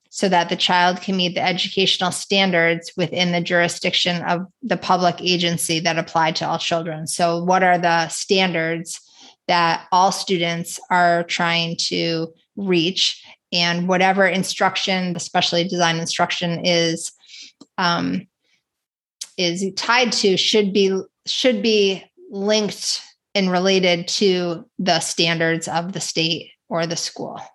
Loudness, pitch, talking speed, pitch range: -19 LUFS, 175 Hz, 135 wpm, 170-190 Hz